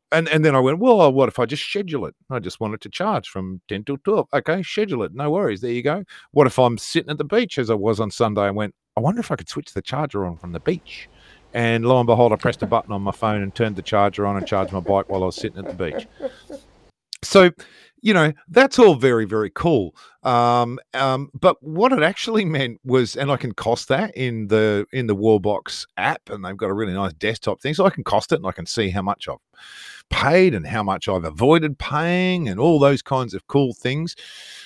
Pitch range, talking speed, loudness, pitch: 105-155 Hz, 250 wpm, -20 LUFS, 130 Hz